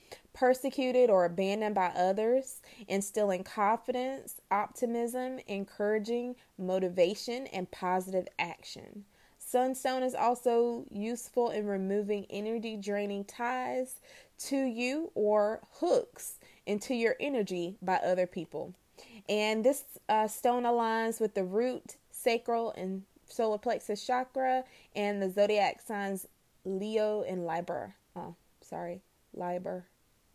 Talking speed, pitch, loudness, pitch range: 110 wpm, 215 Hz, -32 LUFS, 195-250 Hz